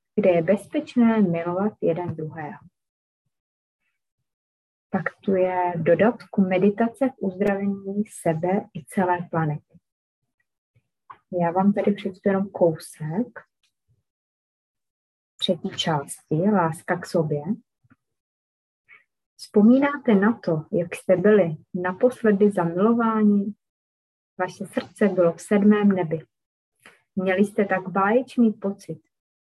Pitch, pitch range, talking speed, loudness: 185 Hz, 165-210 Hz, 95 wpm, -23 LUFS